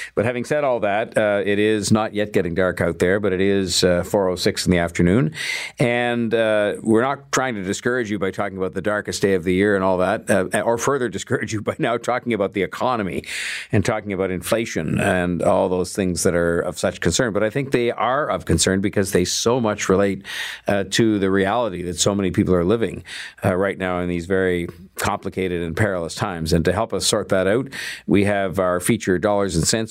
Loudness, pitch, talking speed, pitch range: -20 LUFS, 100 Hz, 225 wpm, 90-110 Hz